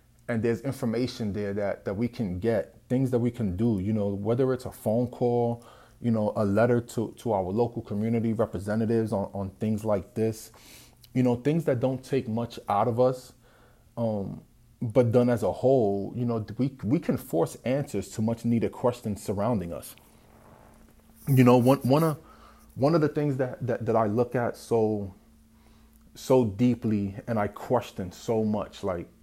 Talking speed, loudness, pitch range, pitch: 185 wpm, -27 LUFS, 105-125 Hz, 115 Hz